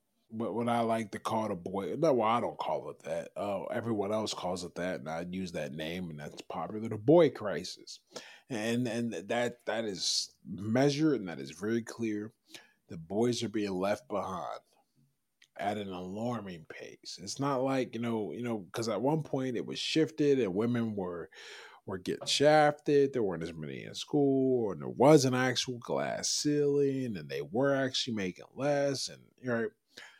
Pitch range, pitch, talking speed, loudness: 105-140 Hz, 120 Hz, 190 wpm, -32 LUFS